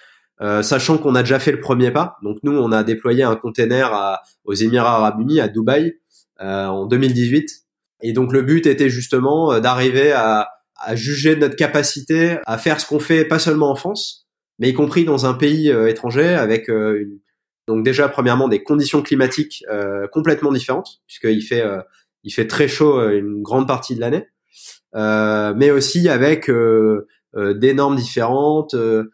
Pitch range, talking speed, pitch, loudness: 110-150 Hz, 185 wpm, 130 Hz, -17 LUFS